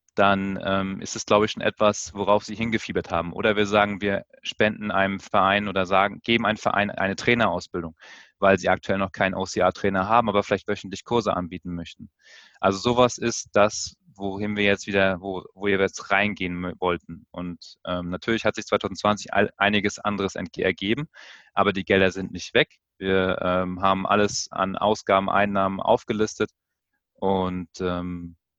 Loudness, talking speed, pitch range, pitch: -24 LUFS, 160 wpm, 95-105 Hz, 95 Hz